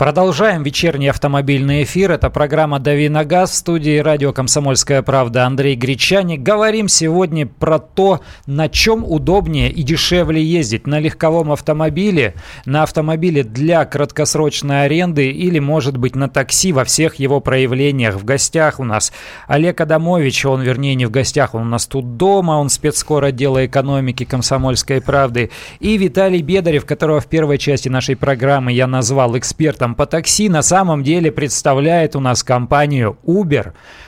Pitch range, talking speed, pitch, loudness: 135-160 Hz, 150 wpm, 145 Hz, -14 LUFS